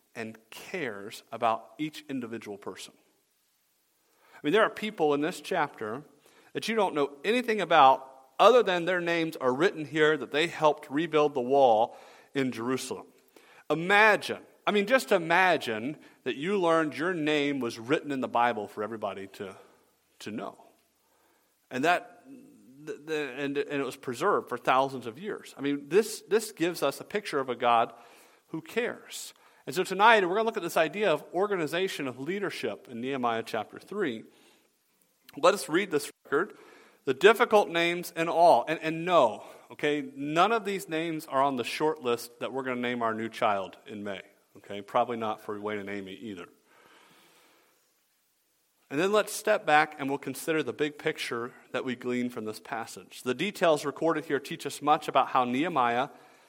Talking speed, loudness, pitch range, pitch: 175 wpm, -28 LUFS, 125-180 Hz, 150 Hz